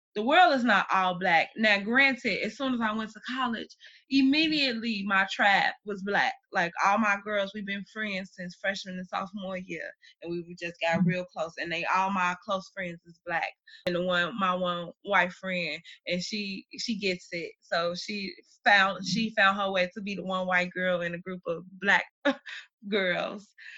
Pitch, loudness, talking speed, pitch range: 195 Hz, -28 LUFS, 195 wpm, 180-220 Hz